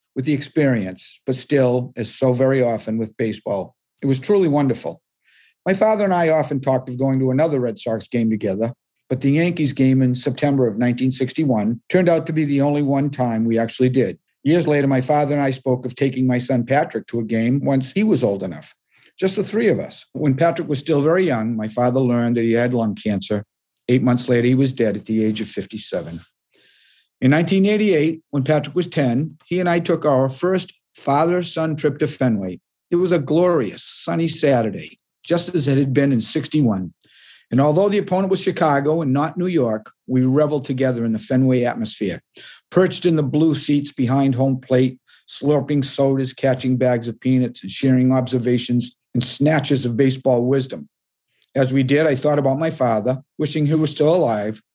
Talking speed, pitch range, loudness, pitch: 195 wpm, 125-150 Hz, -19 LUFS, 135 Hz